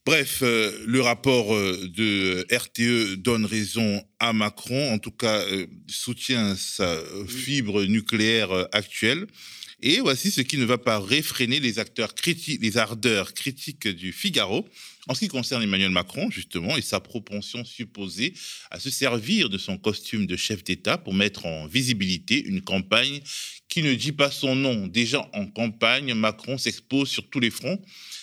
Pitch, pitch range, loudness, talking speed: 115 Hz, 105-135 Hz, -24 LUFS, 160 wpm